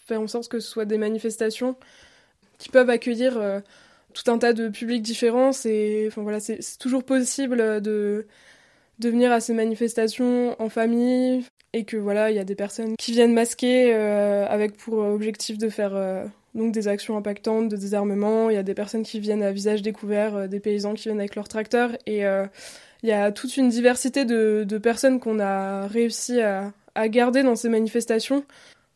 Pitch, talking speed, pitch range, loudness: 225 Hz, 195 wpm, 210-240 Hz, -23 LUFS